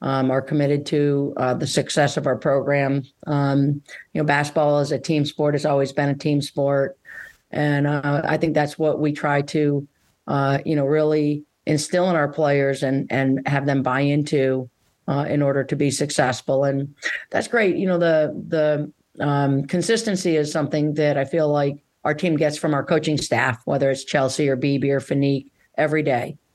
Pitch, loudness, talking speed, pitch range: 145 Hz, -21 LUFS, 190 wpm, 140-150 Hz